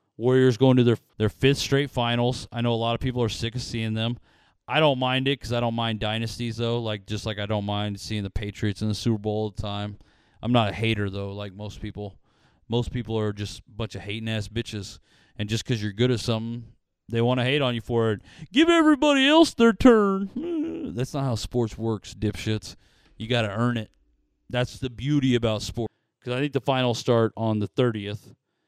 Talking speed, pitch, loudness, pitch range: 225 wpm, 115 Hz, -25 LUFS, 105-125 Hz